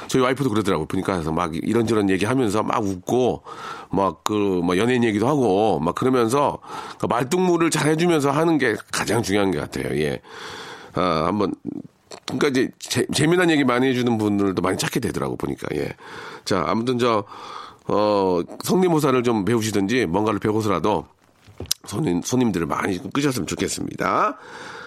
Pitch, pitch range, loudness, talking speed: 115 Hz, 95-150 Hz, -21 LUFS, 350 characters per minute